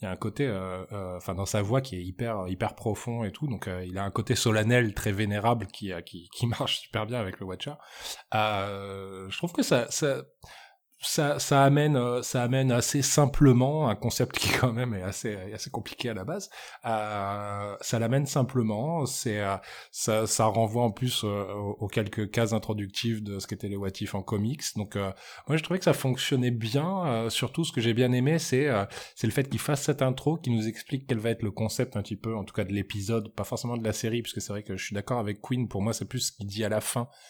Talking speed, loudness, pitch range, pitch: 240 wpm, -29 LUFS, 100-125 Hz, 115 Hz